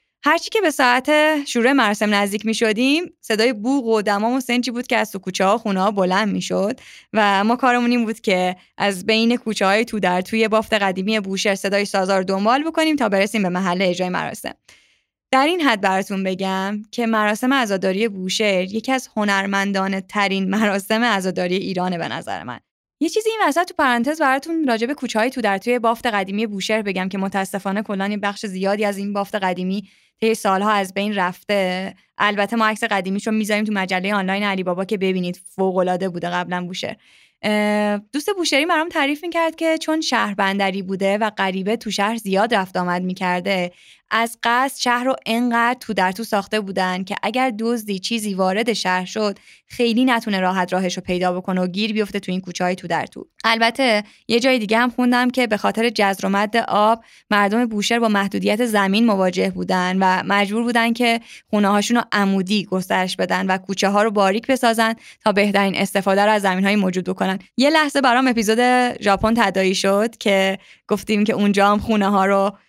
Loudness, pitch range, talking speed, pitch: -19 LUFS, 195-235 Hz, 190 wpm, 210 Hz